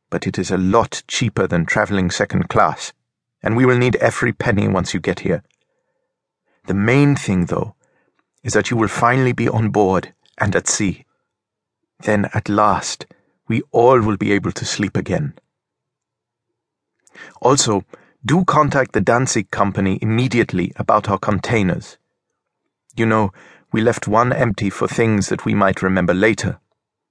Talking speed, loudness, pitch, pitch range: 155 wpm, -17 LUFS, 105 Hz, 95-120 Hz